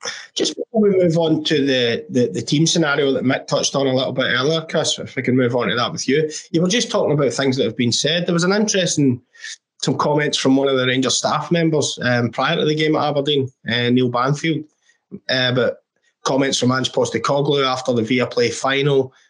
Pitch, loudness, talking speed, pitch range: 140 Hz, -18 LUFS, 230 wpm, 130-160 Hz